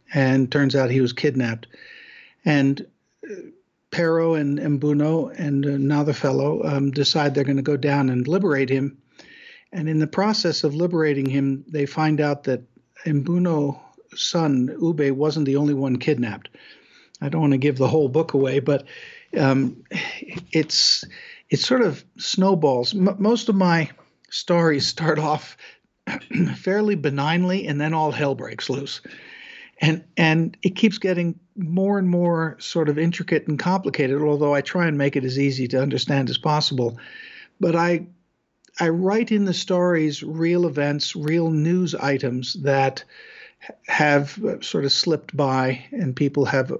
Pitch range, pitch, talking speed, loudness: 140-175 Hz, 150 Hz, 155 wpm, -21 LUFS